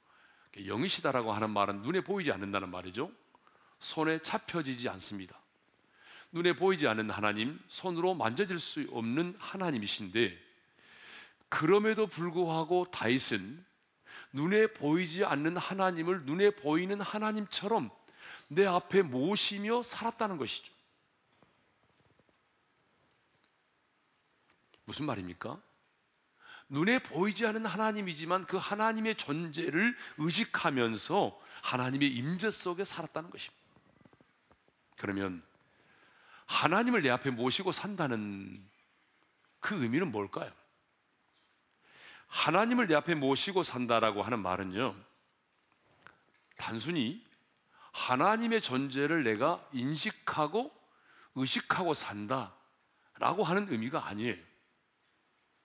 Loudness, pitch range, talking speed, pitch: -32 LUFS, 125-200 Hz, 245 characters per minute, 165 Hz